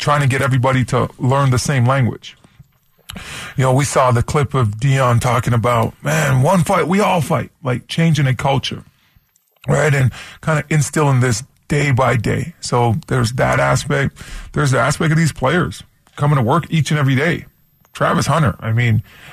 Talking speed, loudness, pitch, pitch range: 185 wpm, -16 LUFS, 135 Hz, 125-150 Hz